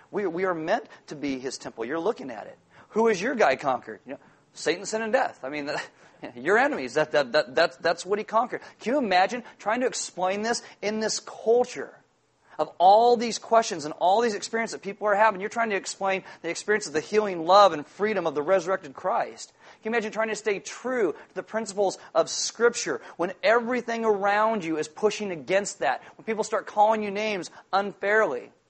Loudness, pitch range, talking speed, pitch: -25 LUFS, 185-225 Hz, 210 wpm, 210 Hz